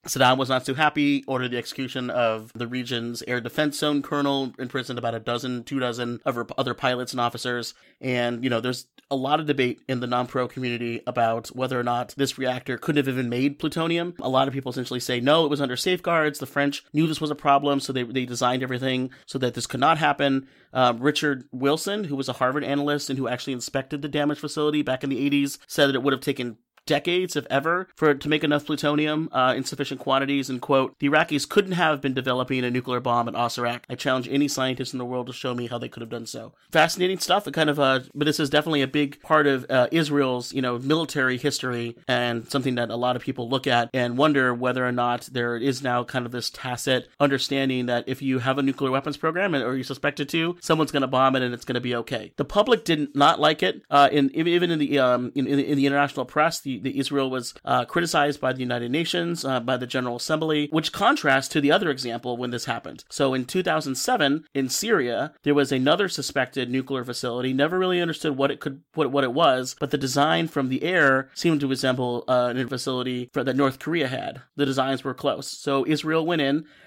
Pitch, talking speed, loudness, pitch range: 135 Hz, 235 wpm, -24 LUFS, 125-145 Hz